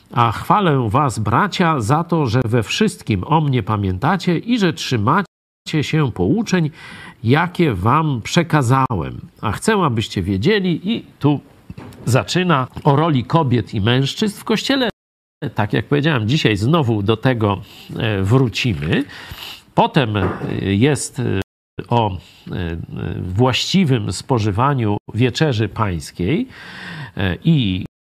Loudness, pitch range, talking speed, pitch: -18 LUFS, 110-165 Hz, 105 wpm, 130 Hz